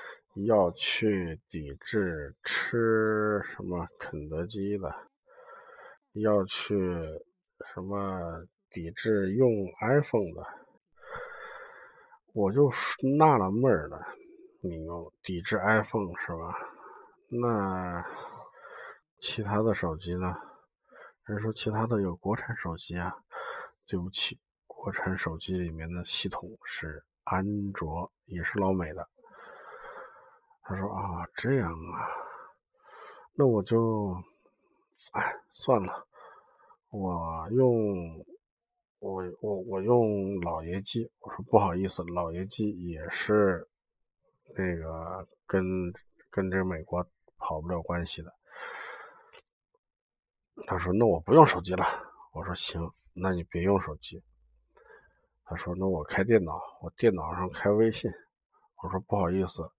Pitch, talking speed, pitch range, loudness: 95 Hz, 165 characters per minute, 90-115 Hz, -30 LUFS